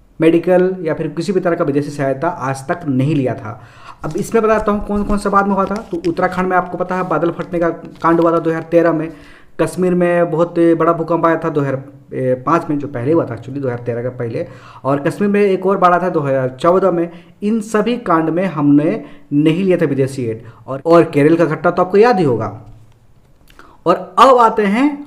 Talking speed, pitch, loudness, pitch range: 225 wpm, 165 Hz, -15 LUFS, 140-180 Hz